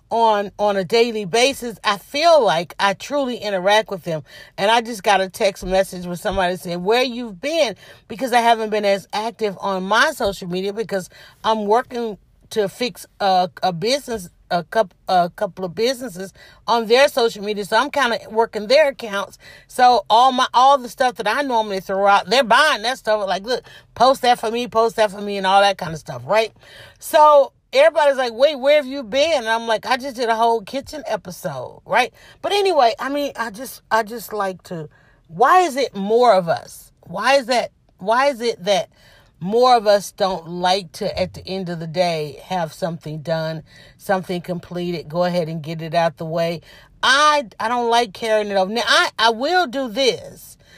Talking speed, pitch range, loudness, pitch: 205 wpm, 185-245 Hz, -19 LUFS, 215 Hz